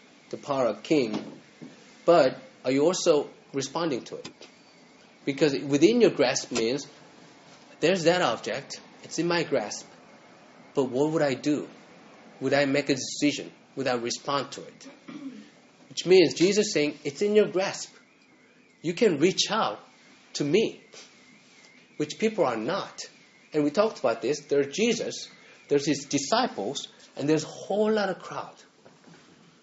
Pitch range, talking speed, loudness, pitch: 140-210 Hz, 150 wpm, -26 LUFS, 155 Hz